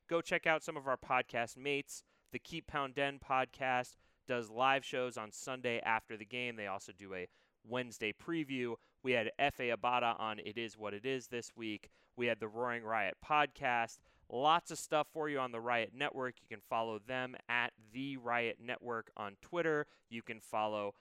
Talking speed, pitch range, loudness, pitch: 190 wpm, 110-135 Hz, -38 LUFS, 120 Hz